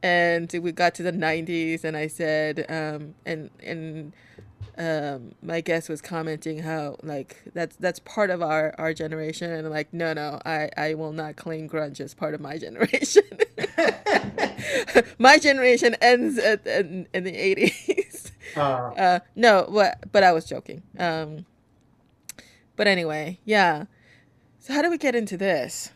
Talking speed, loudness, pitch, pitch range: 155 wpm, -23 LUFS, 165 Hz, 155-200 Hz